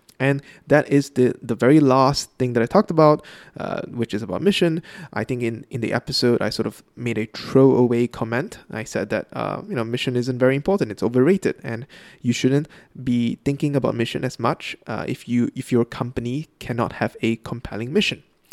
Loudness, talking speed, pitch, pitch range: -21 LUFS, 200 wpm, 130 Hz, 115-145 Hz